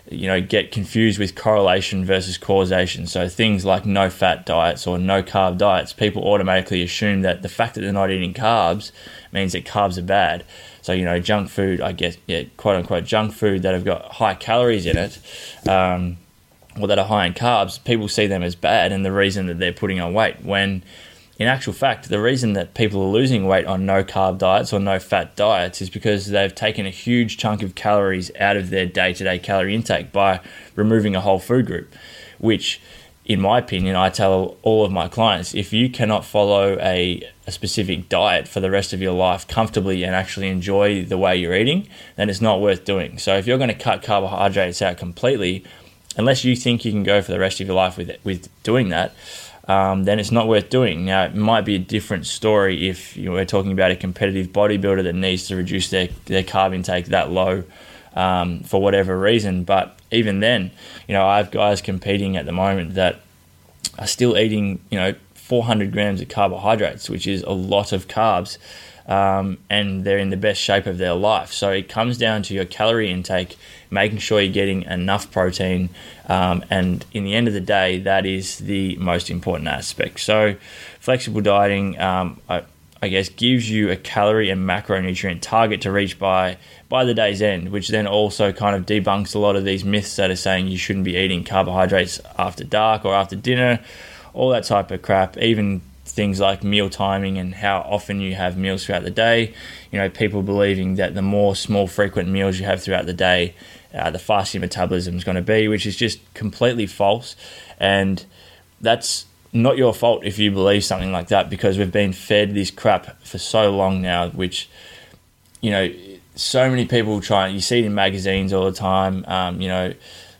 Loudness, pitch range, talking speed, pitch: -19 LUFS, 95-105 Hz, 205 wpm, 95 Hz